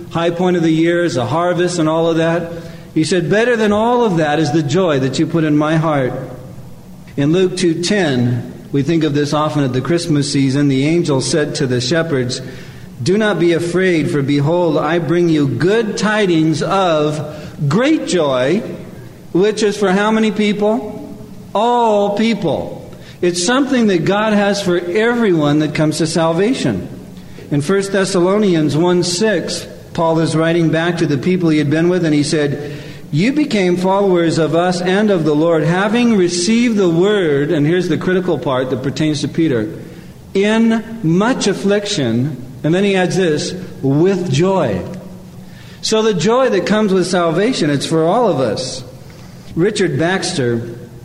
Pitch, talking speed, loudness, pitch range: 170 Hz, 170 wpm, -15 LUFS, 155-195 Hz